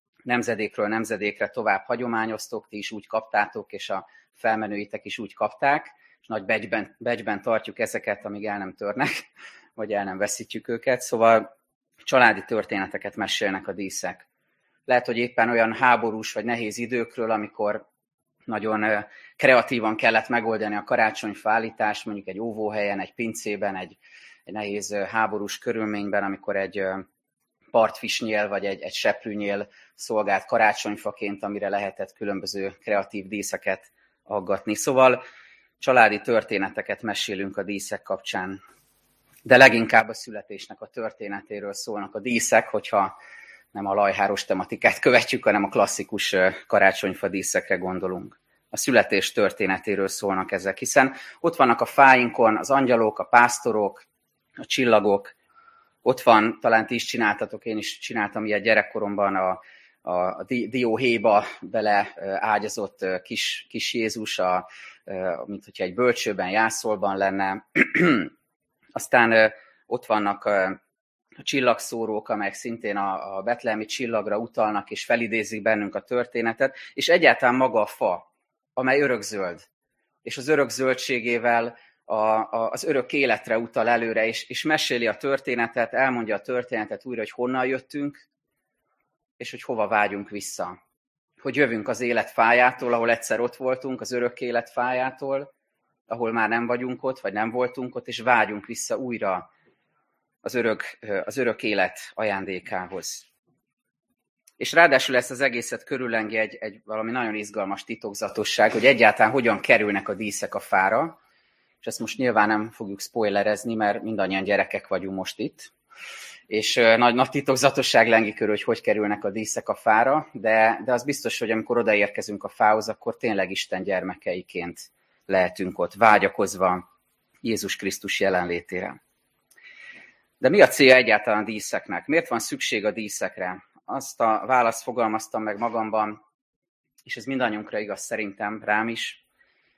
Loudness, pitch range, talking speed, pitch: -23 LUFS, 105-120 Hz, 135 wpm, 110 Hz